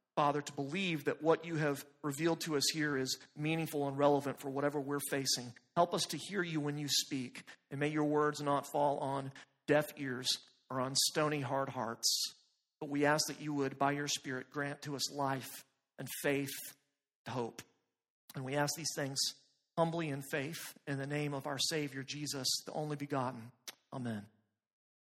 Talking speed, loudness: 185 wpm, -36 LUFS